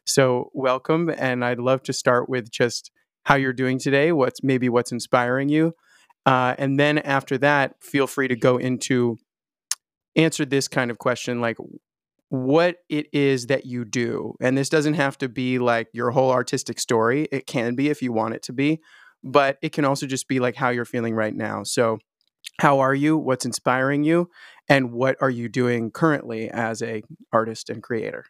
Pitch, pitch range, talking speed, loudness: 130 Hz, 120-140 Hz, 190 wpm, -22 LUFS